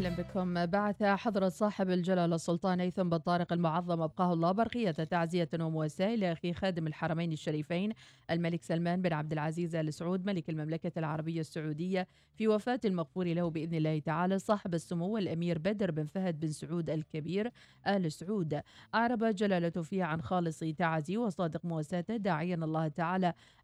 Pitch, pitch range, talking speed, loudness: 175 Hz, 160-190 Hz, 150 wpm, -34 LUFS